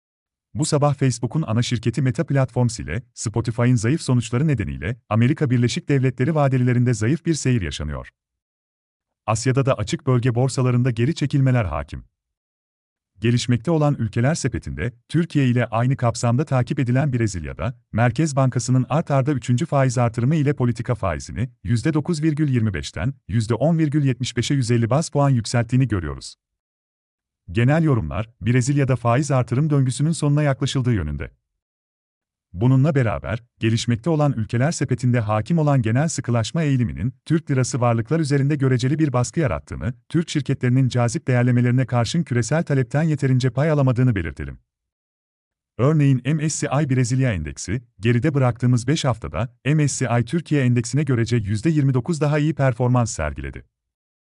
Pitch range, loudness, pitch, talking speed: 115-140 Hz, -21 LUFS, 125 Hz, 125 wpm